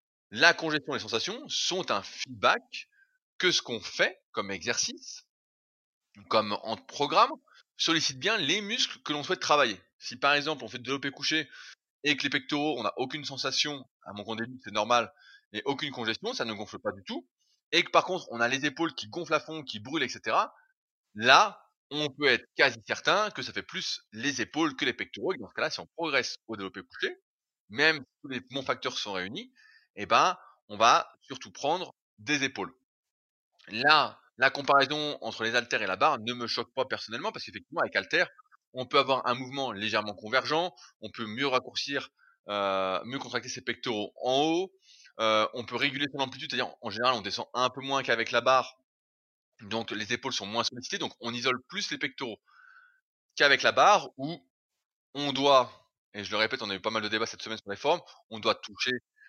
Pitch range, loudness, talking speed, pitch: 115-155 Hz, -28 LUFS, 205 wpm, 135 Hz